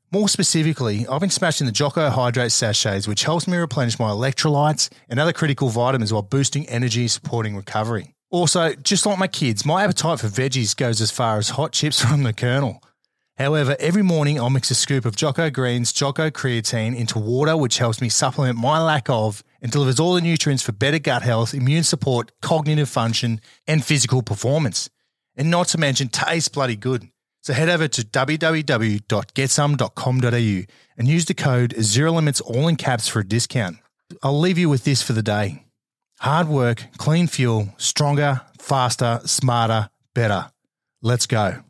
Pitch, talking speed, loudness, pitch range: 135 Hz, 175 wpm, -20 LUFS, 120-155 Hz